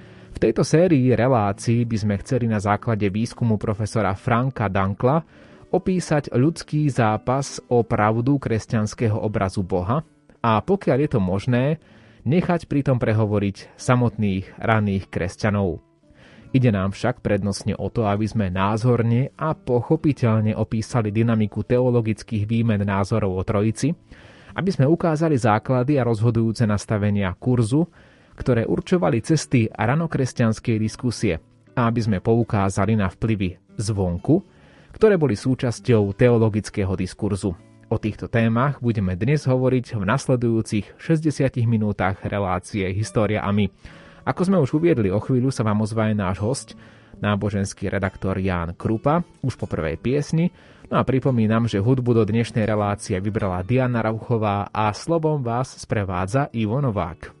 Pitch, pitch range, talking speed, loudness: 115 Hz, 105-130 Hz, 130 wpm, -22 LUFS